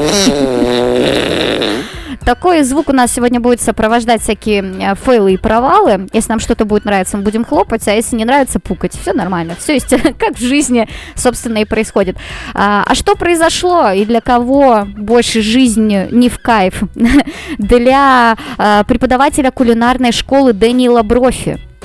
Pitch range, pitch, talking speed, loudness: 210-255 Hz, 235 Hz, 140 wpm, -11 LUFS